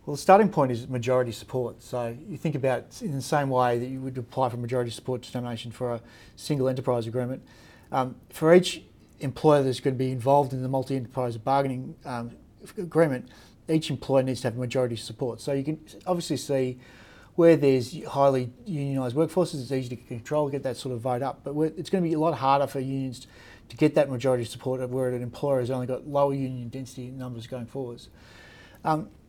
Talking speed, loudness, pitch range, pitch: 205 wpm, -27 LUFS, 125-140 Hz, 130 Hz